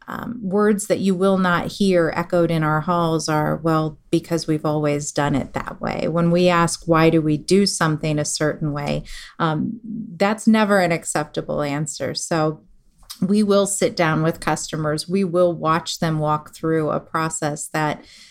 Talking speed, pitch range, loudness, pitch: 175 wpm, 155-190 Hz, -20 LUFS, 165 Hz